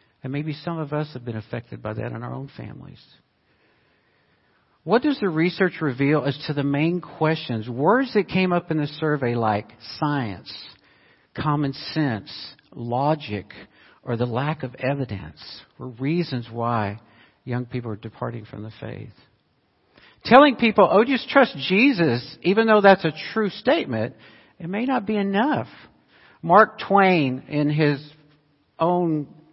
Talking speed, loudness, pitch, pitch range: 150 wpm, -22 LUFS, 150 Hz, 120-180 Hz